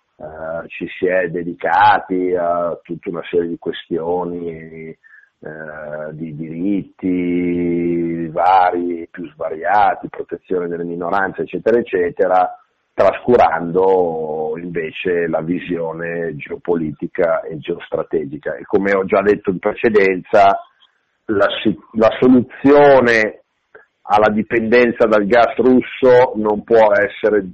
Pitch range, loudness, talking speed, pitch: 85-105 Hz, -16 LUFS, 100 wpm, 90 Hz